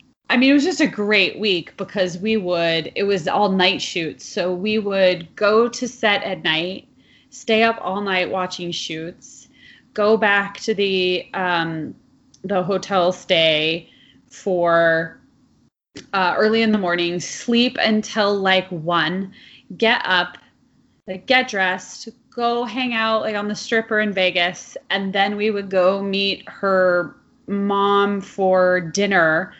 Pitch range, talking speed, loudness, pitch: 180-215 Hz, 145 wpm, -19 LUFS, 195 Hz